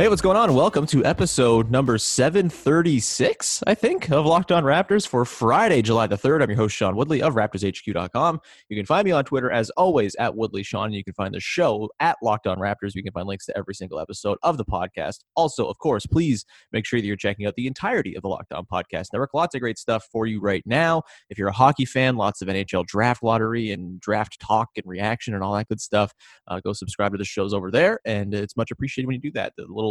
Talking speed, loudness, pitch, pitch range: 250 wpm, -22 LUFS, 110 Hz, 100-130 Hz